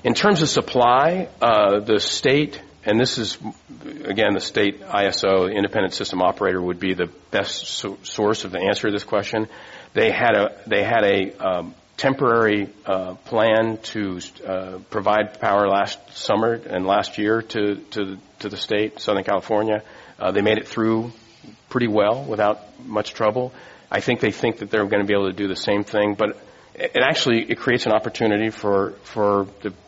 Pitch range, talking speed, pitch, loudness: 100-110 Hz, 180 wpm, 105 Hz, -21 LUFS